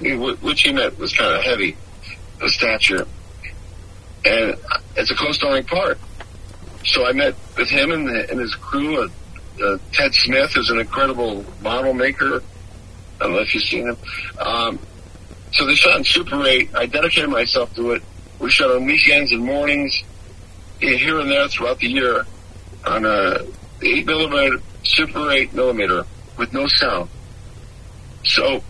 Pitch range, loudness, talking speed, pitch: 95-135 Hz, -17 LUFS, 155 wpm, 100 Hz